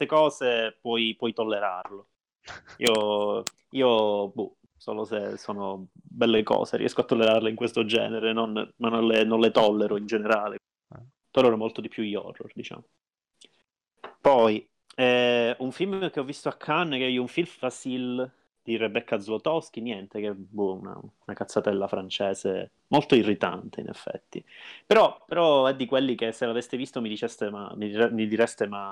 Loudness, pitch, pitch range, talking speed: -26 LUFS, 115 Hz, 105-130 Hz, 165 wpm